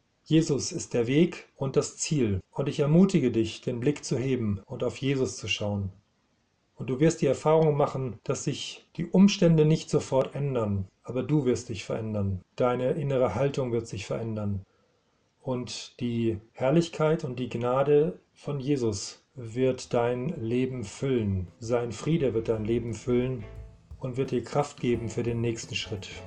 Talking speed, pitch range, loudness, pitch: 160 wpm, 115-145 Hz, -28 LUFS, 125 Hz